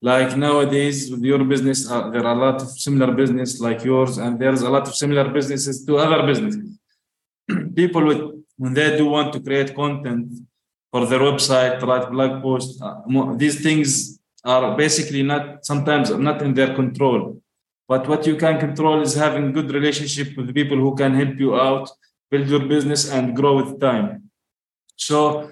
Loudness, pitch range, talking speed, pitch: -19 LUFS, 130-150 Hz, 175 wpm, 140 Hz